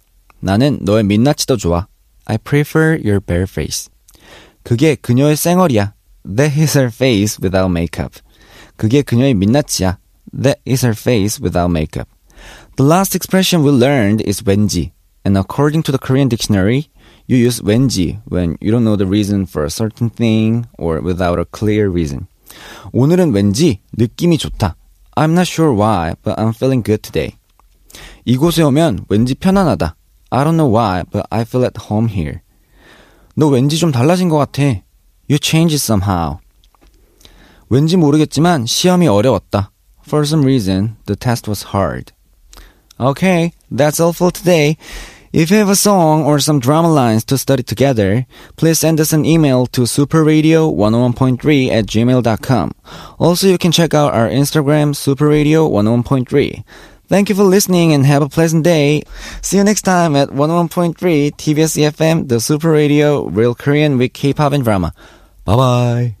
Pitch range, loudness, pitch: 105-155 Hz, -14 LUFS, 130 Hz